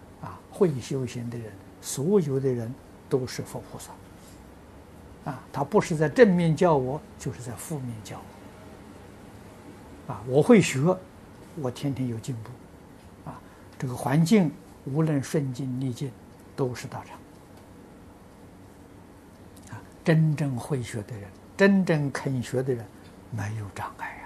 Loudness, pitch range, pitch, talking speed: -26 LUFS, 100-140 Hz, 125 Hz, 180 characters per minute